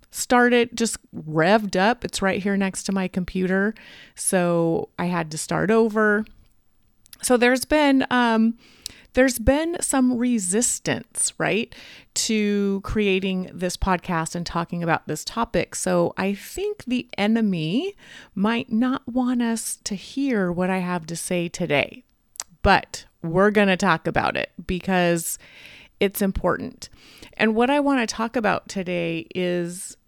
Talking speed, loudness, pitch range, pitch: 140 wpm, -22 LUFS, 180-245 Hz, 205 Hz